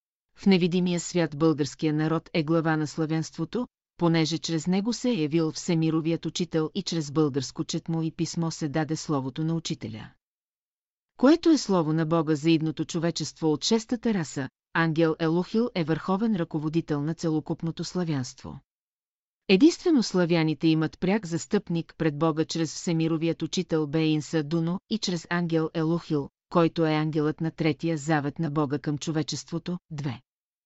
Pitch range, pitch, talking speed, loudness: 155-175 Hz, 165 Hz, 145 wpm, -26 LUFS